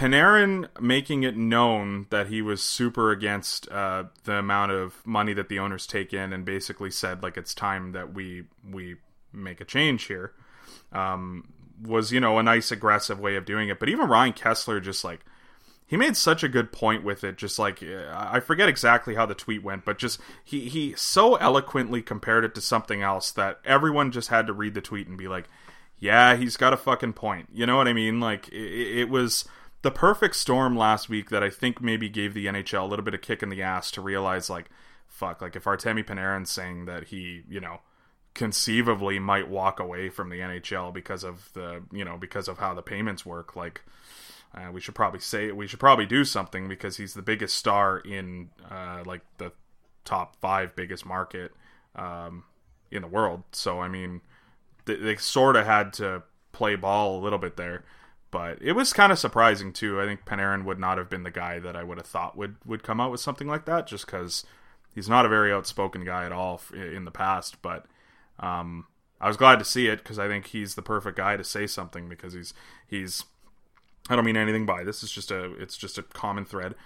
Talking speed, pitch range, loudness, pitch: 215 wpm, 95-115 Hz, -25 LUFS, 100 Hz